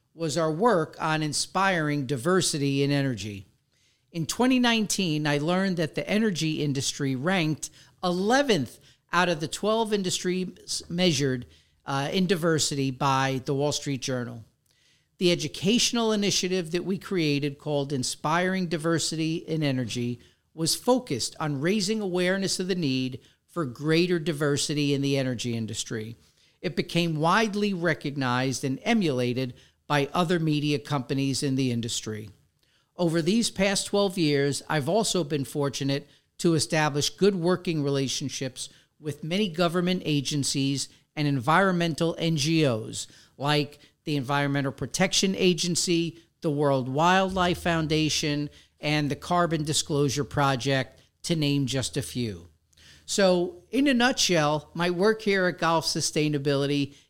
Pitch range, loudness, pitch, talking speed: 140-180 Hz, -26 LUFS, 155 Hz, 125 wpm